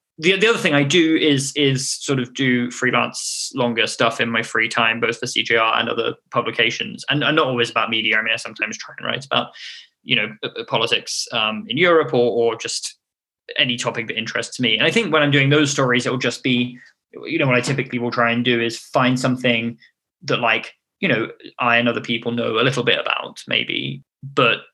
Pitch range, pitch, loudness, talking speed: 115-140 Hz, 125 Hz, -19 LUFS, 220 wpm